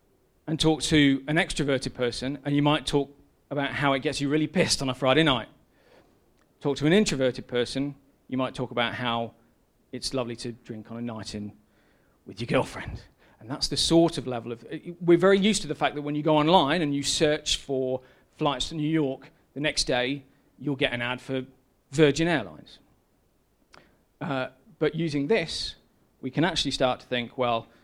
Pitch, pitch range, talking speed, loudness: 140 Hz, 125-155 Hz, 190 wpm, -26 LUFS